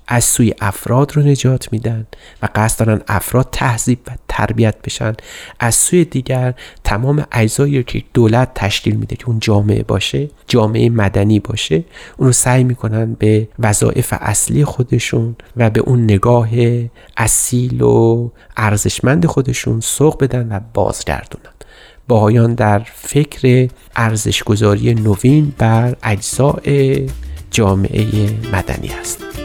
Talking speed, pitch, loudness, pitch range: 125 wpm, 115 Hz, -14 LUFS, 105-125 Hz